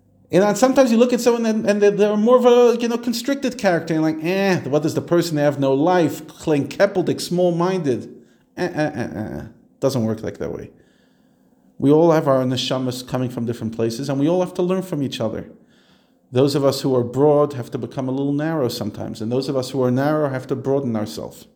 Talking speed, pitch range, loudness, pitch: 230 wpm, 125-180 Hz, -19 LUFS, 145 Hz